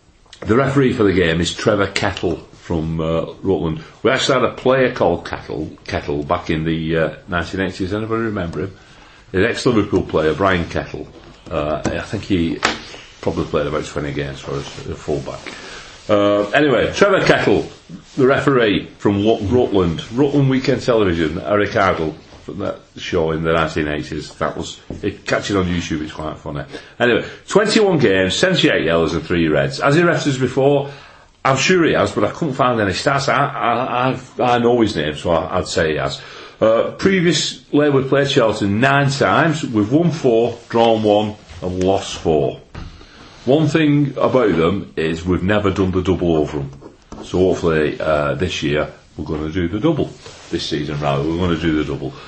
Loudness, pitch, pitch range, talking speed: -17 LUFS, 95 Hz, 80-115 Hz, 180 wpm